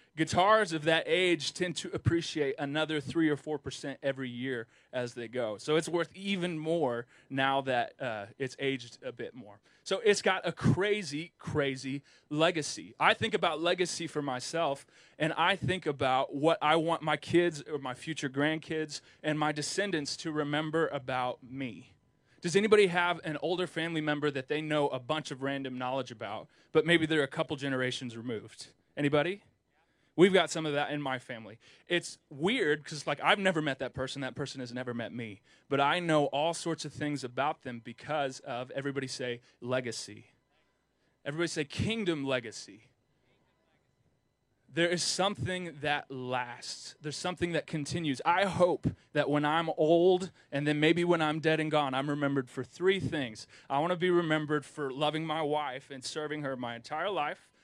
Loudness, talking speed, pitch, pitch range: -31 LUFS, 180 wpm, 150 Hz, 135-165 Hz